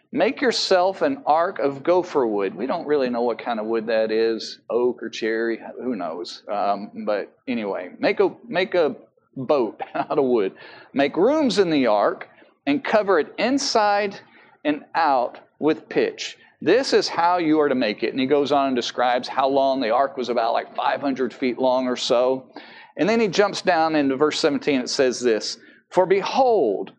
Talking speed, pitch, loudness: 190 wpm, 155 Hz, -22 LUFS